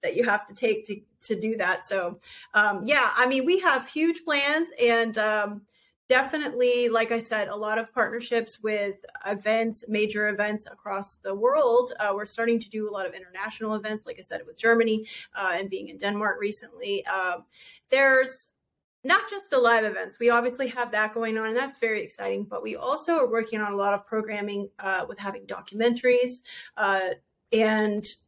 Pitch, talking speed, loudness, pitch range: 225 Hz, 190 wpm, -26 LUFS, 210-250 Hz